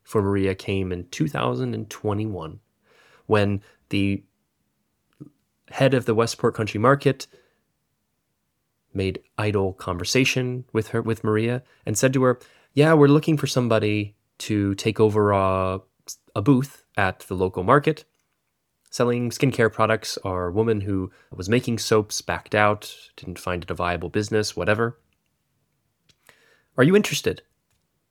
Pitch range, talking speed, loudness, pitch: 95-120 Hz, 130 wpm, -23 LUFS, 110 Hz